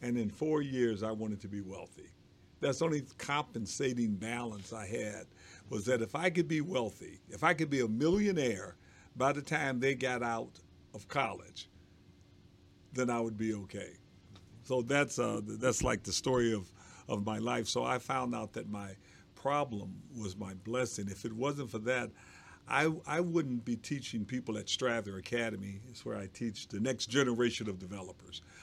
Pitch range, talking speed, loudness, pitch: 100-130 Hz, 180 wpm, -35 LUFS, 115 Hz